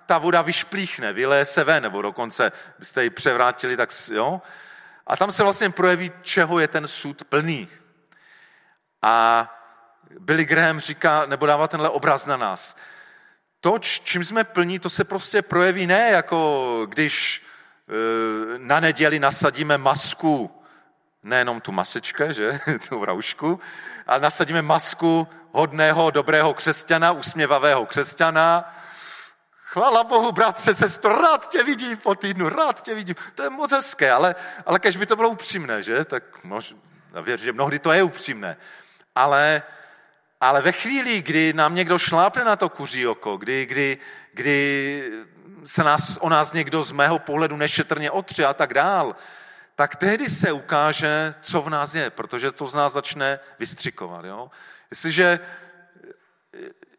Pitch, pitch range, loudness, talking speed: 160 Hz, 145-185 Hz, -20 LUFS, 145 wpm